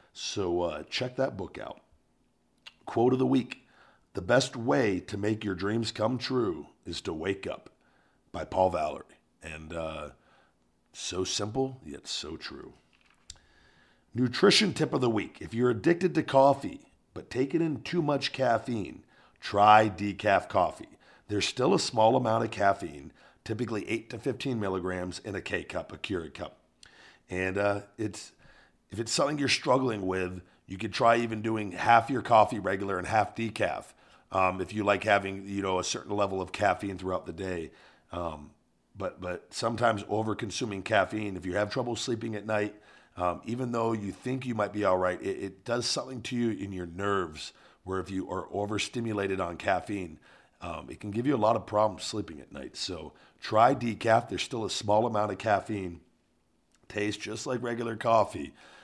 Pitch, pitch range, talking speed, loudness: 105 Hz, 95-120 Hz, 175 wpm, -29 LUFS